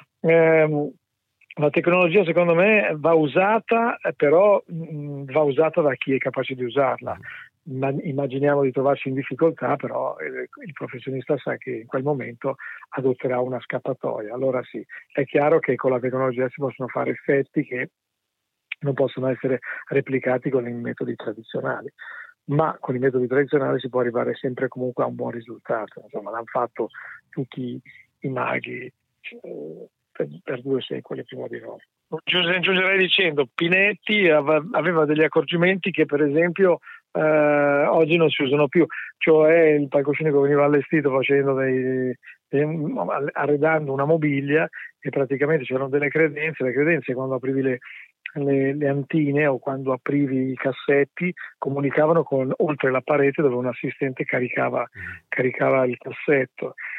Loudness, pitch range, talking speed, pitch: -22 LUFS, 130-155 Hz, 140 wpm, 140 Hz